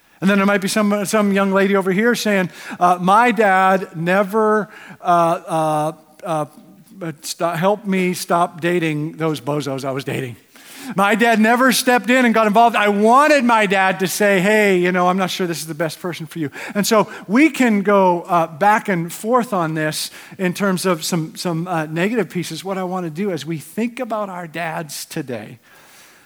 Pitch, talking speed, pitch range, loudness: 190 Hz, 200 wpm, 165-210 Hz, -17 LUFS